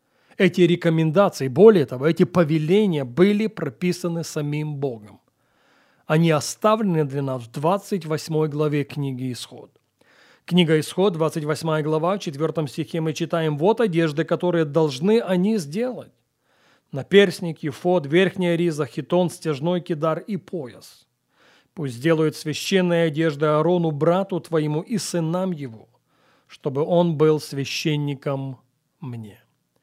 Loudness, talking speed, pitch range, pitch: -21 LUFS, 115 wpm, 150-180 Hz, 160 Hz